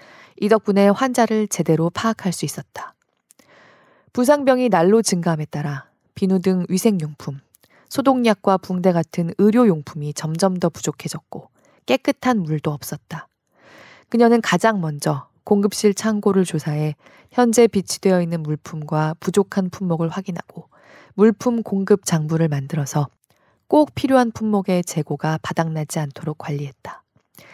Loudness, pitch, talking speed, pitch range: -20 LUFS, 185 Hz, 290 characters per minute, 155-215 Hz